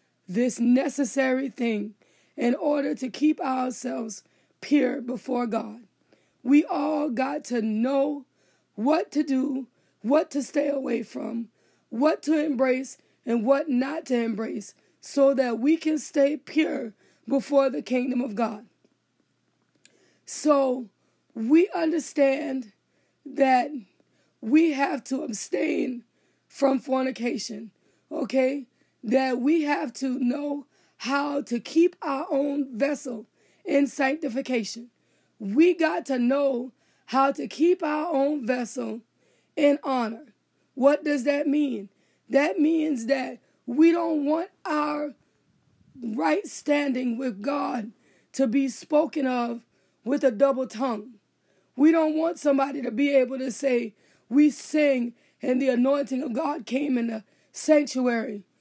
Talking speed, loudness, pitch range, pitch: 125 wpm, -25 LUFS, 245-290 Hz, 270 Hz